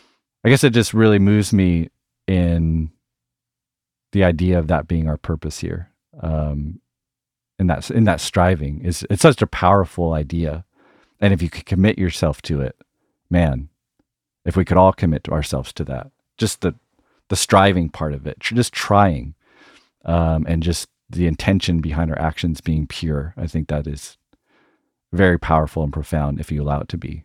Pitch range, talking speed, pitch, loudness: 75-95 Hz, 170 wpm, 85 Hz, -19 LUFS